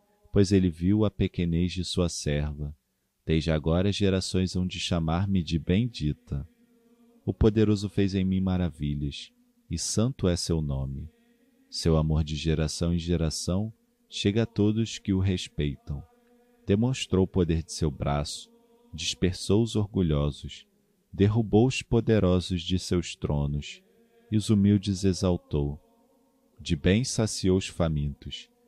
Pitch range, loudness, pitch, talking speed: 85-110 Hz, -27 LUFS, 95 Hz, 130 wpm